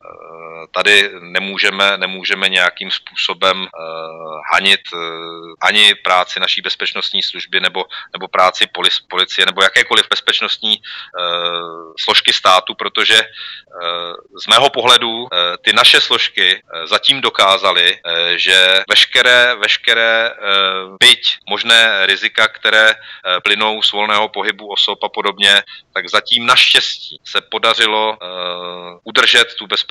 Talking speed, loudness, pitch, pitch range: 125 wpm, -12 LUFS, 95 Hz, 85-110 Hz